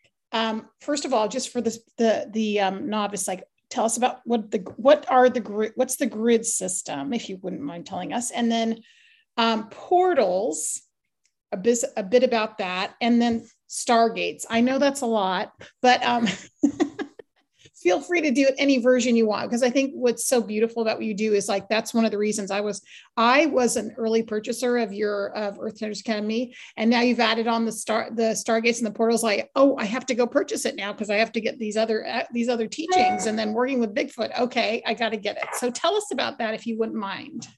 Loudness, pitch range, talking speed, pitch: -24 LUFS, 220-250 Hz, 225 wpm, 230 Hz